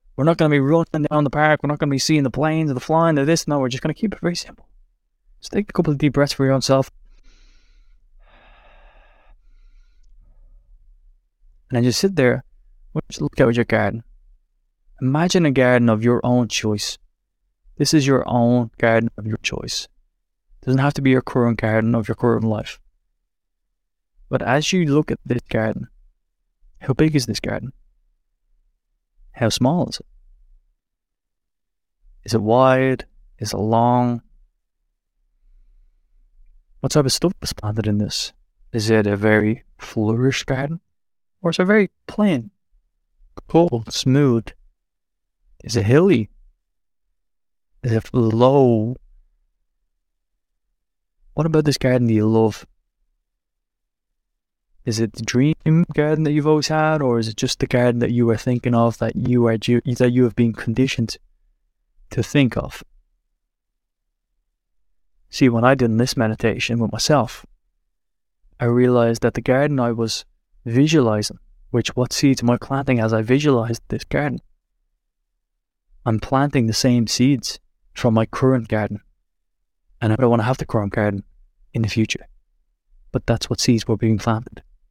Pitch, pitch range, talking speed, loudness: 120 Hz, 110-135 Hz, 155 wpm, -19 LUFS